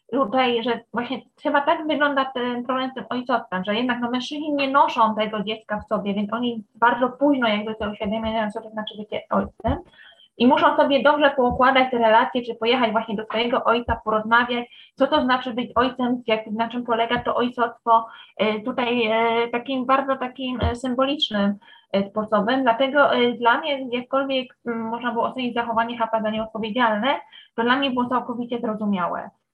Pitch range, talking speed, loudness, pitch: 225-255 Hz, 175 wpm, -22 LUFS, 240 Hz